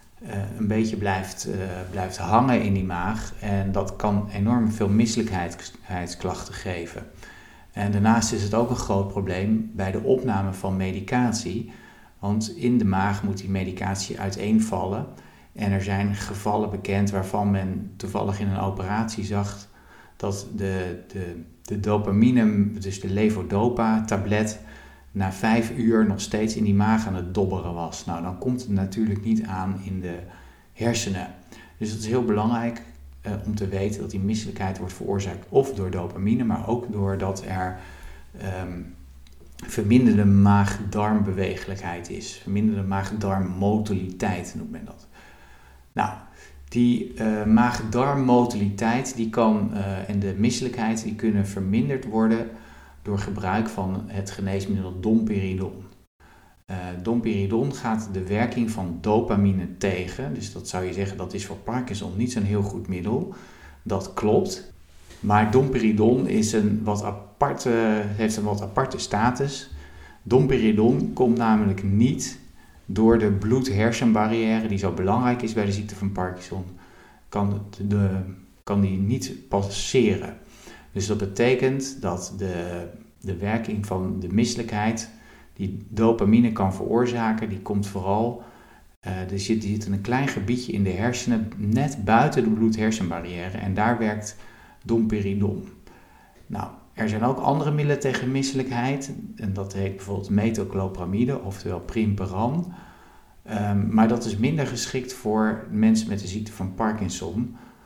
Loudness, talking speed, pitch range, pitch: -24 LUFS, 140 wpm, 95-110 Hz, 105 Hz